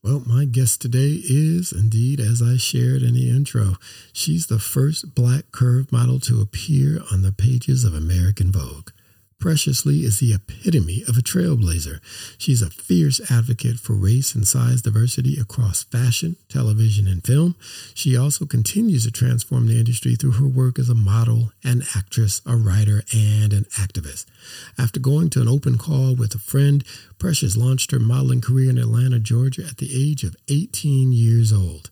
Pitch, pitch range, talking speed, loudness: 120 Hz, 110-135 Hz, 175 wpm, -19 LUFS